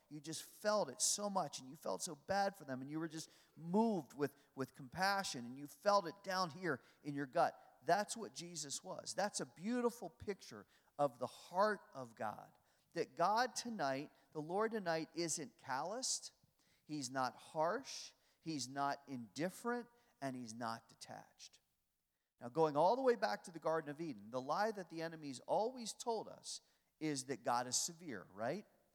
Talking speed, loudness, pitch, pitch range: 180 wpm, -41 LUFS, 160 Hz, 140-200 Hz